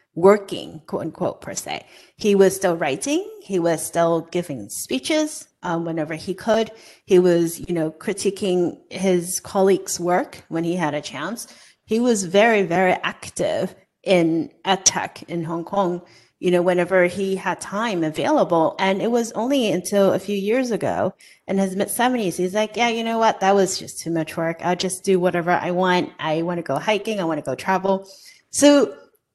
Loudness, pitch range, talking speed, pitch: -21 LUFS, 170-205 Hz, 180 wpm, 185 Hz